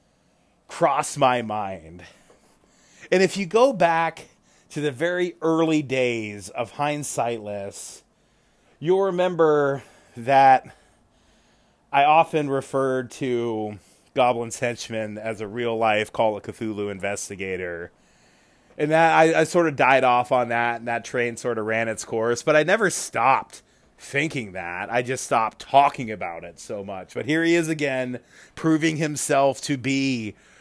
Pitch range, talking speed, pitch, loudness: 110-155 Hz, 140 wpm, 125 Hz, -22 LUFS